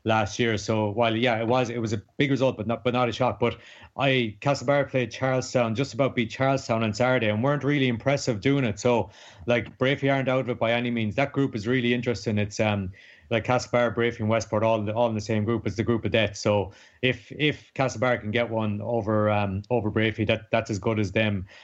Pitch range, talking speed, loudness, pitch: 110-130 Hz, 235 wpm, -25 LUFS, 115 Hz